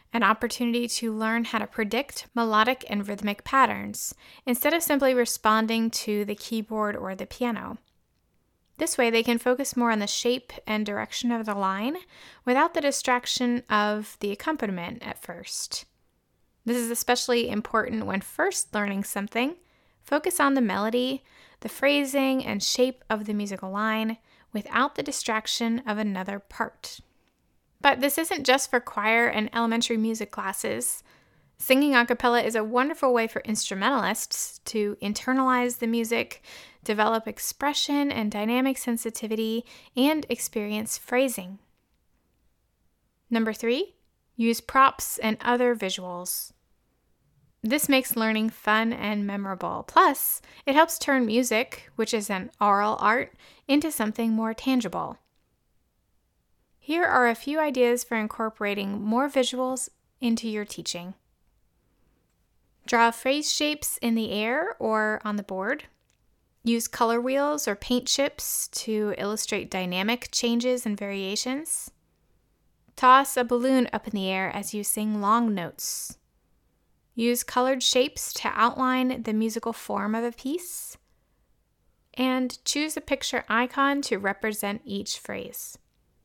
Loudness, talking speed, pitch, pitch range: -26 LUFS, 135 wpm, 230 Hz, 210-255 Hz